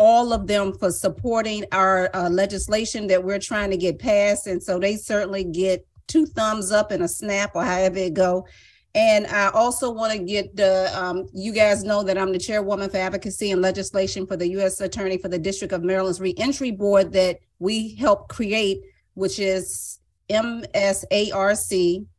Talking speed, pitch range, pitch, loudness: 180 wpm, 185-215 Hz, 195 Hz, -22 LUFS